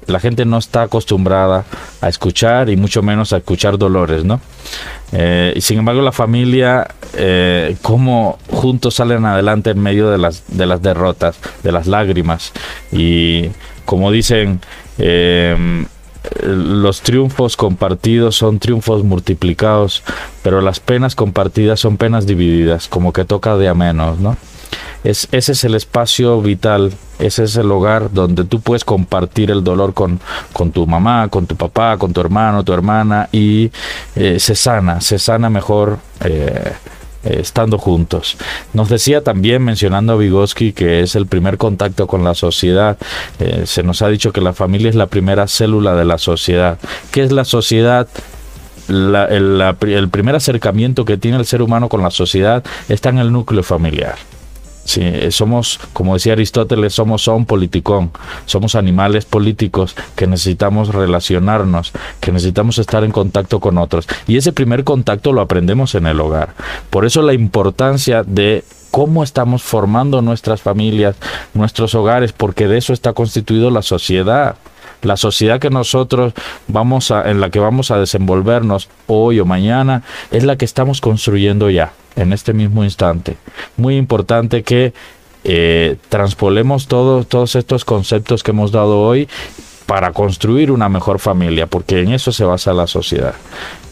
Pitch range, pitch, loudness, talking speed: 95-115 Hz, 105 Hz, -13 LUFS, 160 wpm